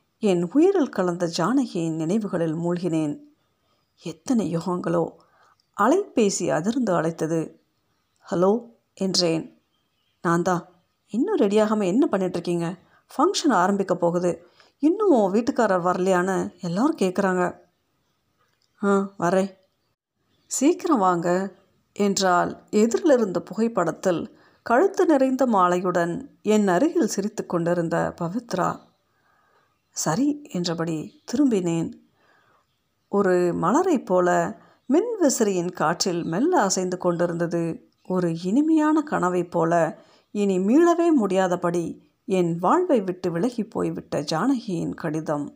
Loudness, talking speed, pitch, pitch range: -23 LUFS, 85 wpm, 190 Hz, 175-255 Hz